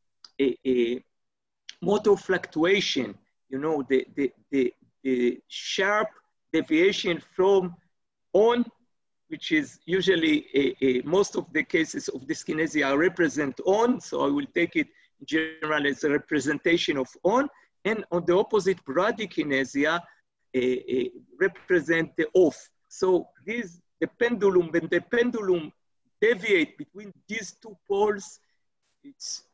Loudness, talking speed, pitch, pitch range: -26 LUFS, 120 wpm, 185 Hz, 155-225 Hz